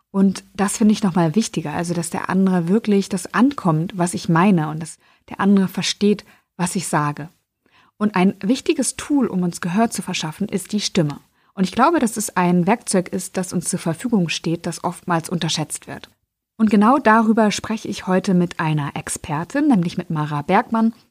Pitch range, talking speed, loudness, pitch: 175-215 Hz, 190 wpm, -19 LUFS, 190 Hz